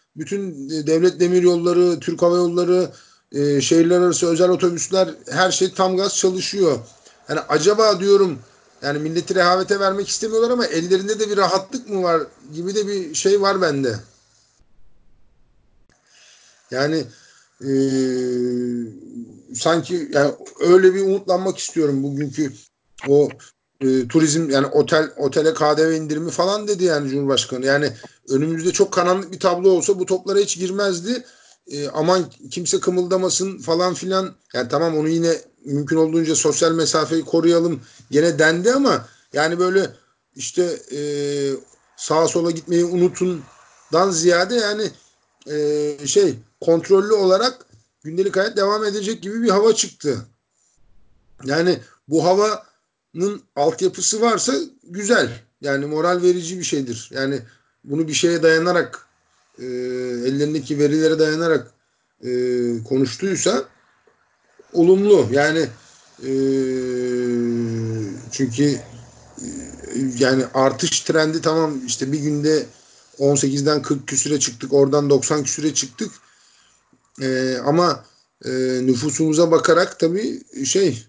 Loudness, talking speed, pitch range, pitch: -19 LUFS, 115 wpm, 140-185 Hz, 160 Hz